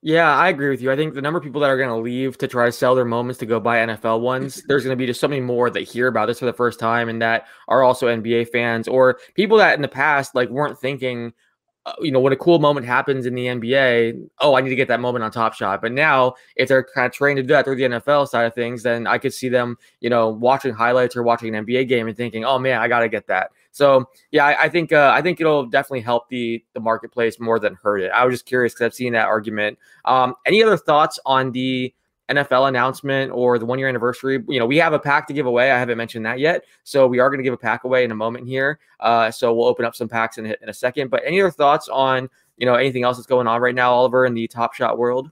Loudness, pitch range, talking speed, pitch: -19 LUFS, 120-135 Hz, 280 wpm, 125 Hz